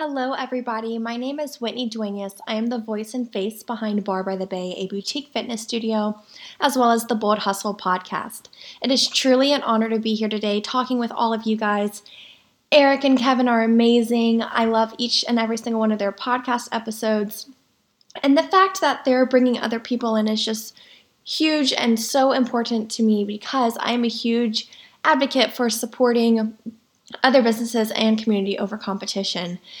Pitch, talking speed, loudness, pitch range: 230 Hz, 185 wpm, -21 LUFS, 215-250 Hz